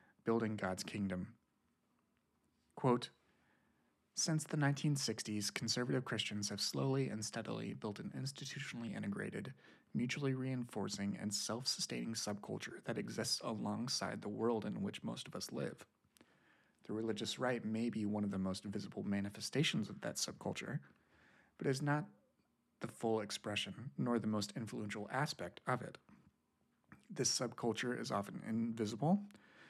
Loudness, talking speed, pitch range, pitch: -40 LUFS, 135 wpm, 105-130 Hz, 115 Hz